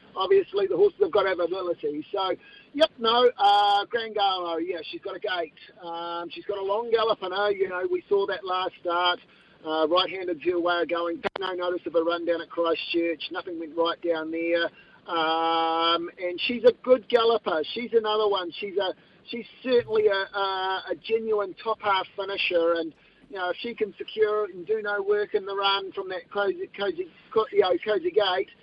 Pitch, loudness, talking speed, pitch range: 195 Hz, -26 LUFS, 195 wpm, 170-220 Hz